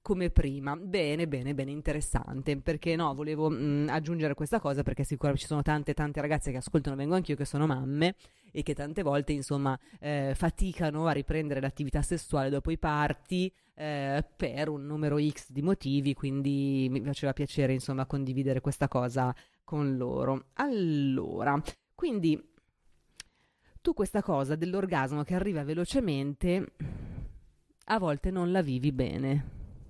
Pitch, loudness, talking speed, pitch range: 150 Hz, -31 LUFS, 145 wpm, 140-165 Hz